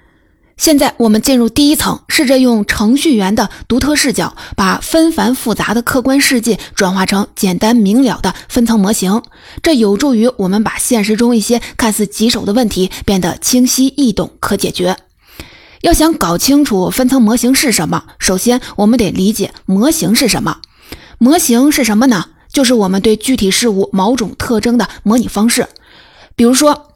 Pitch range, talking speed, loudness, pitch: 205-260 Hz, 270 characters per minute, -12 LUFS, 235 Hz